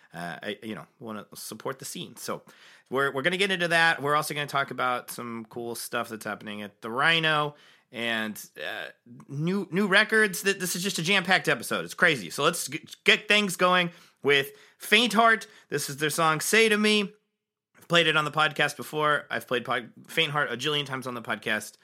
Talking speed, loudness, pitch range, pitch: 210 wpm, -25 LUFS, 130-190 Hz, 155 Hz